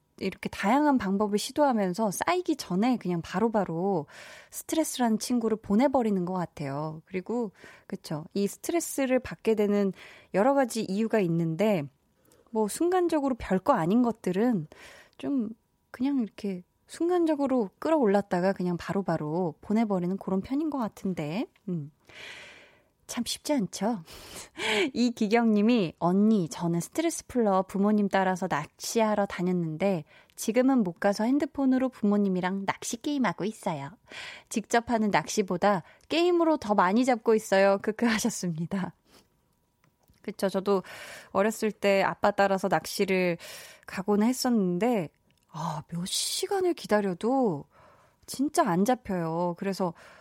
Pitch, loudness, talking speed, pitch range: 205 Hz, -28 LUFS, 295 characters per minute, 185-245 Hz